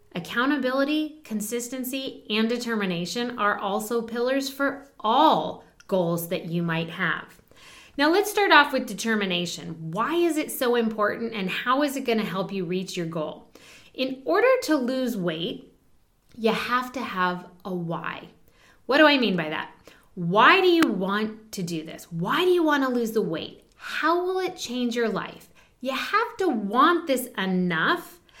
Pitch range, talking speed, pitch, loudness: 190-280 Hz, 170 wpm, 235 Hz, -24 LUFS